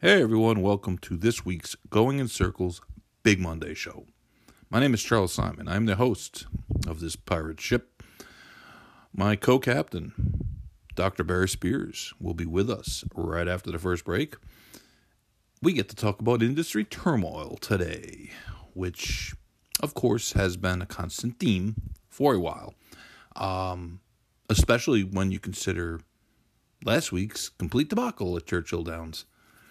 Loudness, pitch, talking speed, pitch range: -28 LUFS, 95 Hz, 140 wpm, 90-110 Hz